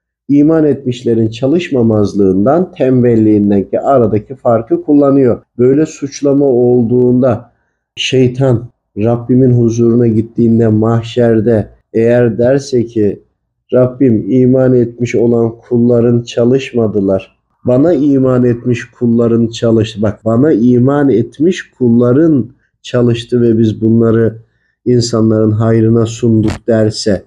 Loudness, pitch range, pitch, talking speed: -11 LUFS, 115-125 Hz, 120 Hz, 95 wpm